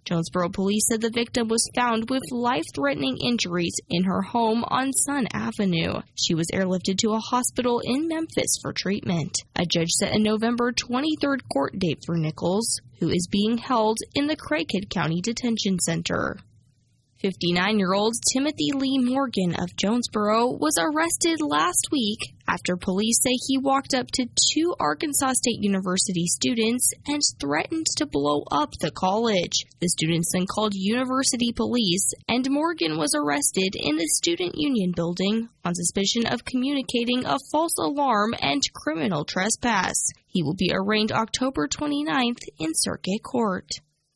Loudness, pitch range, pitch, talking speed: -24 LUFS, 180-260 Hz, 220 Hz, 150 wpm